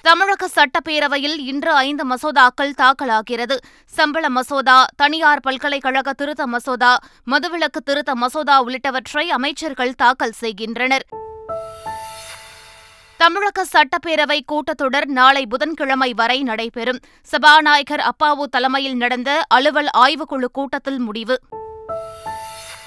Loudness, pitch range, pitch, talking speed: -16 LUFS, 250-300 Hz, 275 Hz, 90 wpm